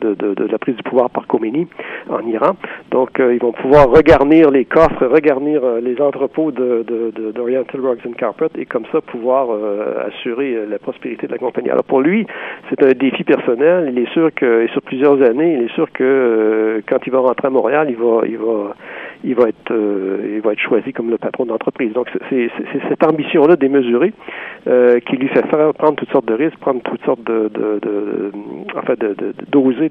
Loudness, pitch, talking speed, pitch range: -15 LUFS, 130 Hz, 225 wpm, 115-145 Hz